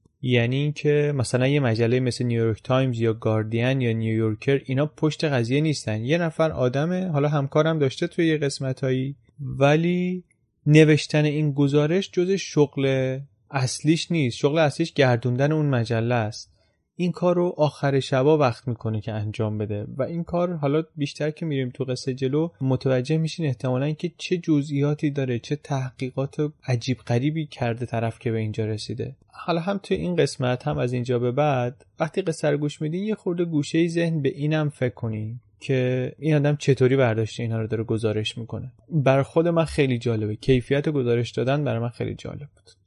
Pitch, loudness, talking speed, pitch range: 135 Hz, -24 LUFS, 170 wpm, 120-155 Hz